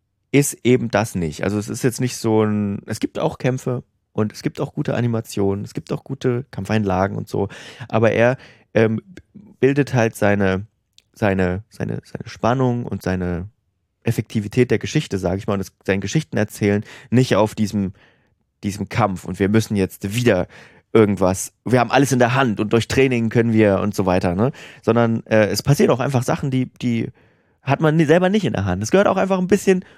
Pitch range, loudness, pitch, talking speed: 100-125 Hz, -20 LUFS, 110 Hz, 195 wpm